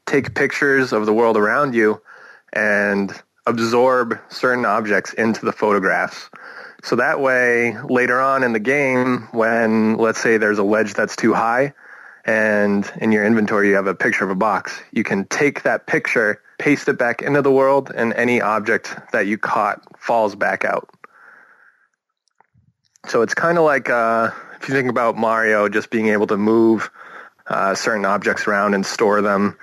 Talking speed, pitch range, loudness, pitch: 170 wpm, 105-125 Hz, -18 LUFS, 115 Hz